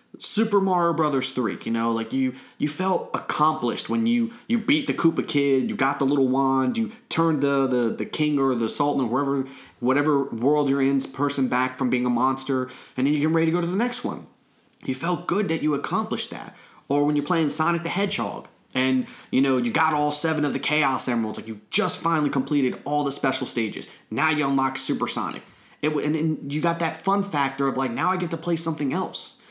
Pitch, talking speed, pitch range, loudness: 145 Hz, 225 wpm, 130-165 Hz, -24 LUFS